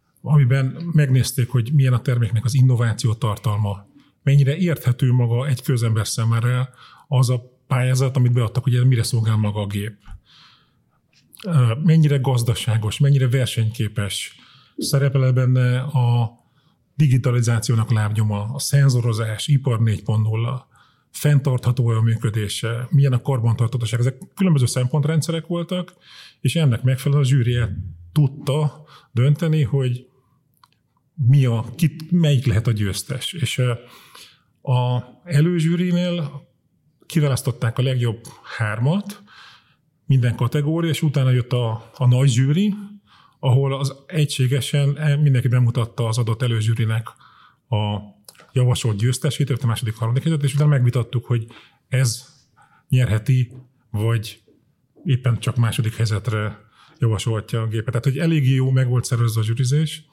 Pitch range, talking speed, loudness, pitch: 115-140 Hz, 120 wpm, -20 LUFS, 130 Hz